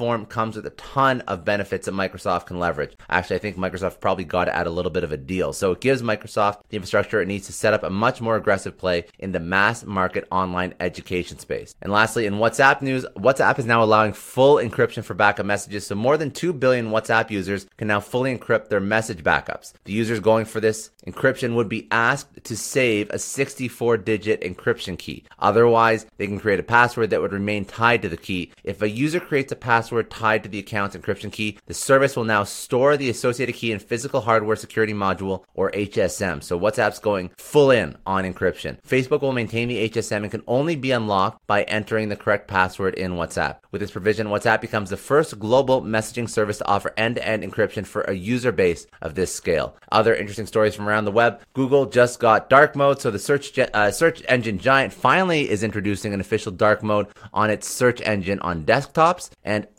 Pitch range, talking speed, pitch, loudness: 100-120 Hz, 210 wpm, 110 Hz, -21 LUFS